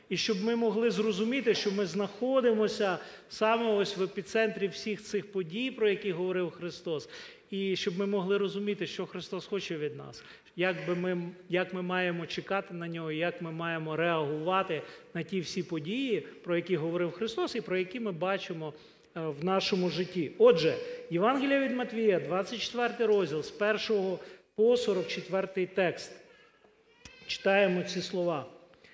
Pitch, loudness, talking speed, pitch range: 195 Hz, -31 LUFS, 150 wpm, 180-220 Hz